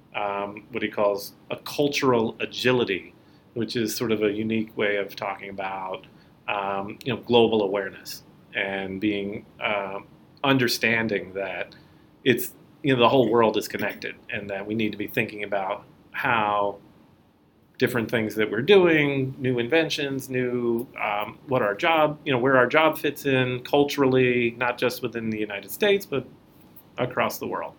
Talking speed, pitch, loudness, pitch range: 160 wpm, 115 Hz, -24 LUFS, 105-130 Hz